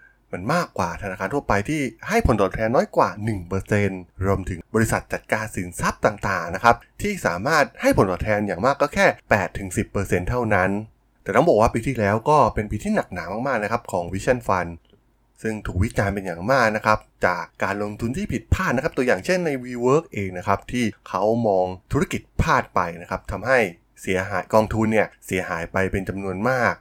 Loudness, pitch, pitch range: -22 LUFS, 105 Hz, 95-115 Hz